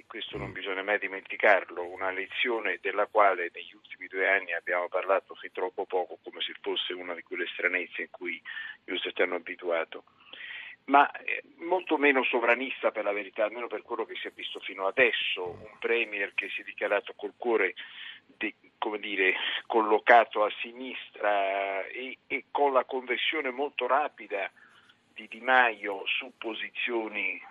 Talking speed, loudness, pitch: 160 wpm, -29 LUFS, 125 Hz